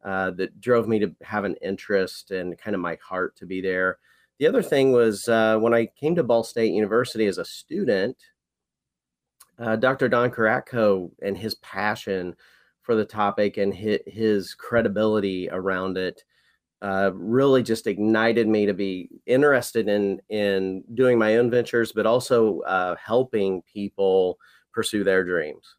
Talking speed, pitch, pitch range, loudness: 160 wpm, 105 Hz, 95-115 Hz, -23 LUFS